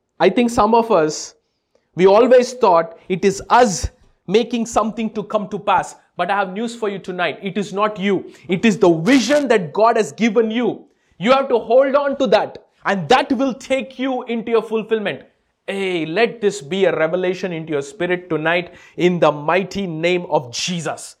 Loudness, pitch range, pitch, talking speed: -18 LUFS, 180-235 Hz, 205 Hz, 190 wpm